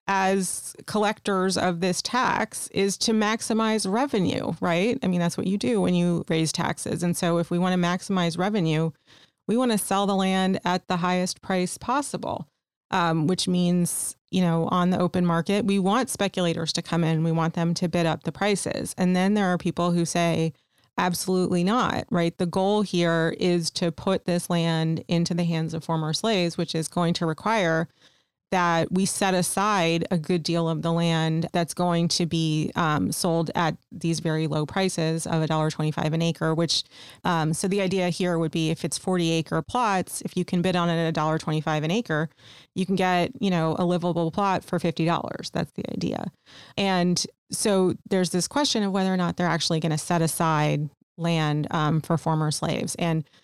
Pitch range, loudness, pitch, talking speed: 165-190 Hz, -25 LUFS, 175 Hz, 195 wpm